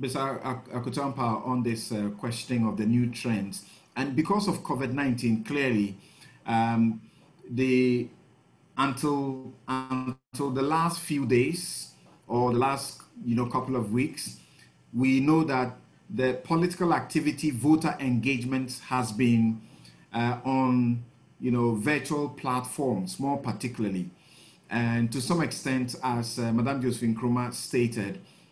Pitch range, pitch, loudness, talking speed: 115-135 Hz, 125 Hz, -28 LUFS, 125 wpm